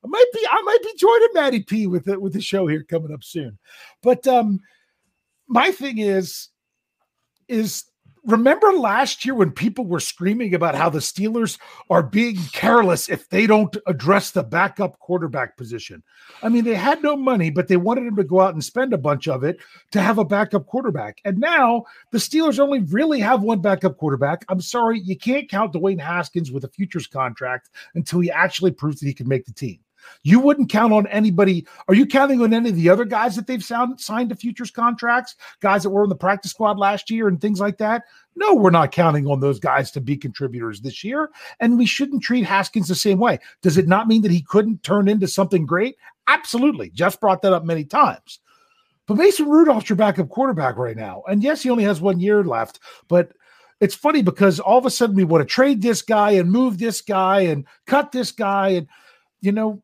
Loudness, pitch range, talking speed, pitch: -19 LUFS, 175-235 Hz, 215 wpm, 200 Hz